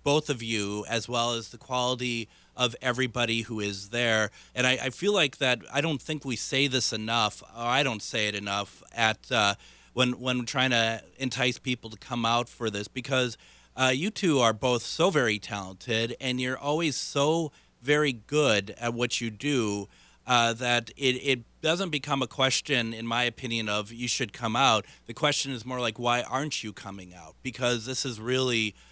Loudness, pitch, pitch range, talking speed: -27 LUFS, 120 Hz, 115-130 Hz, 195 wpm